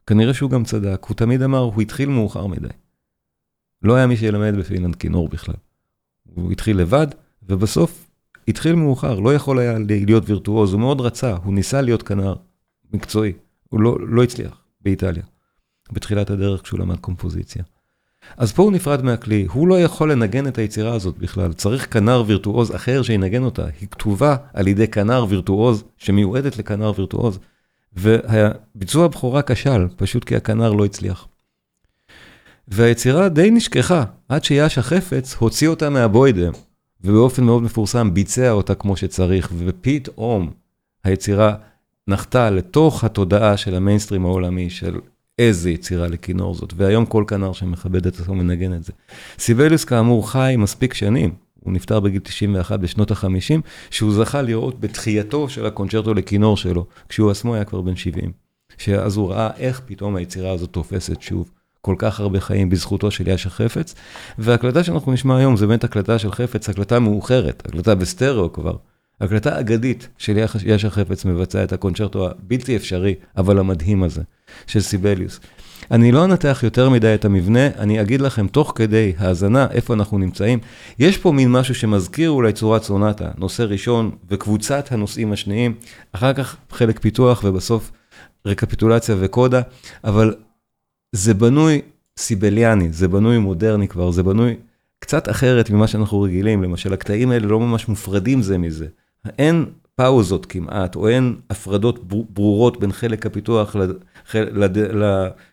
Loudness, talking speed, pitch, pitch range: -18 LUFS, 150 wpm, 105 Hz, 95-120 Hz